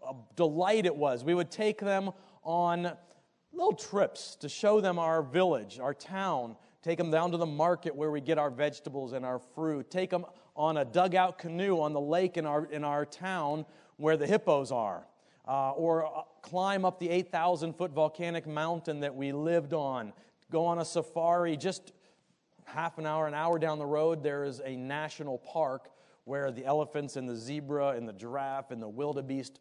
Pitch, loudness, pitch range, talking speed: 160 Hz, -32 LUFS, 145-175 Hz, 185 wpm